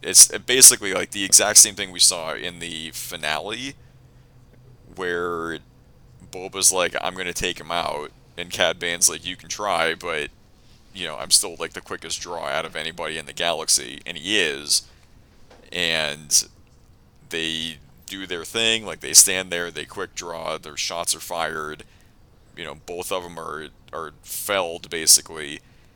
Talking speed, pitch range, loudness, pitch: 160 wpm, 80-115 Hz, -19 LUFS, 90 Hz